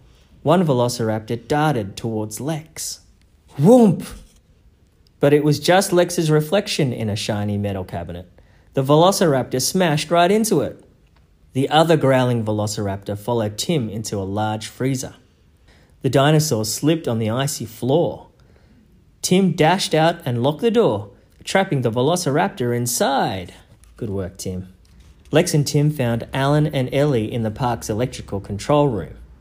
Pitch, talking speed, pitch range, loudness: 120 Hz, 135 wpm, 105-150 Hz, -19 LUFS